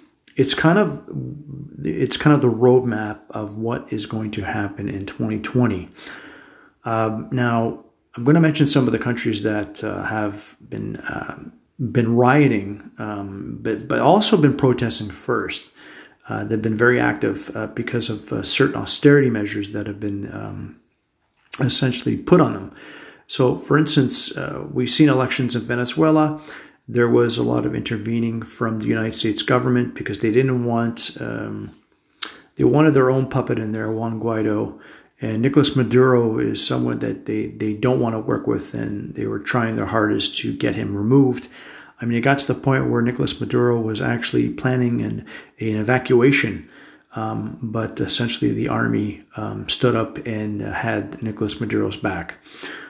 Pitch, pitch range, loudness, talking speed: 115 Hz, 105-125 Hz, -20 LUFS, 165 wpm